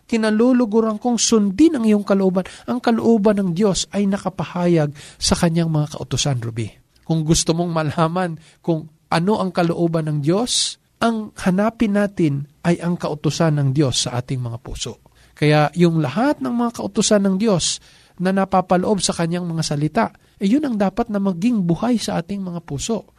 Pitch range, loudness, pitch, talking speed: 155-215 Hz, -19 LUFS, 185 Hz, 165 wpm